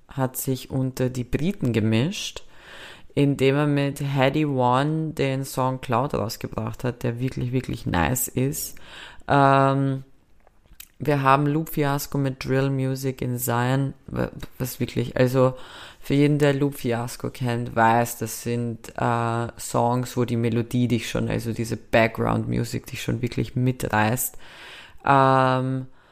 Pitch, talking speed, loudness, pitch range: 130 Hz, 135 wpm, -24 LUFS, 120-135 Hz